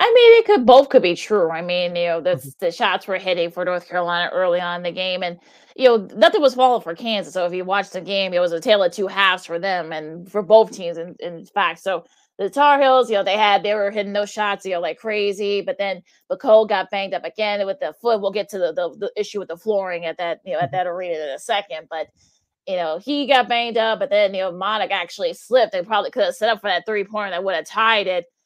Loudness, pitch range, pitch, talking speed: -19 LUFS, 175-220 Hz, 200 Hz, 280 wpm